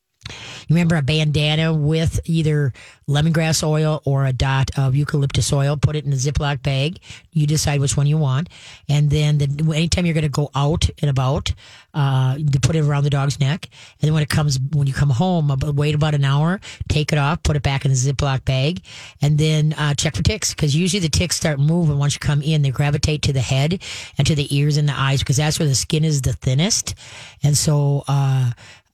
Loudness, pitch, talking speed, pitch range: -19 LUFS, 145 Hz, 220 wpm, 135-155 Hz